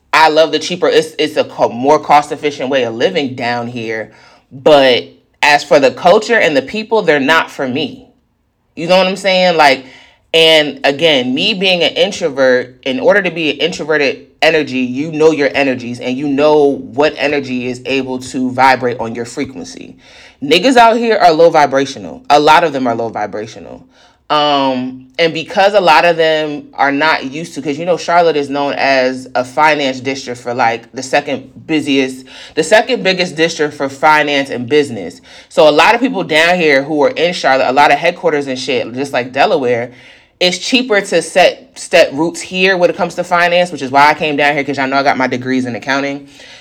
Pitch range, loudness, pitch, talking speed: 130-175 Hz, -12 LUFS, 150 Hz, 205 wpm